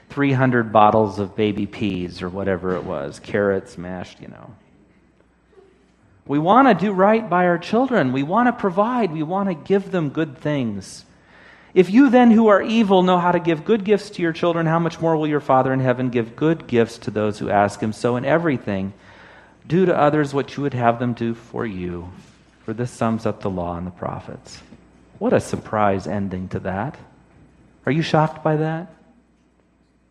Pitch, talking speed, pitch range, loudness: 135 Hz, 195 wpm, 105-175 Hz, -20 LUFS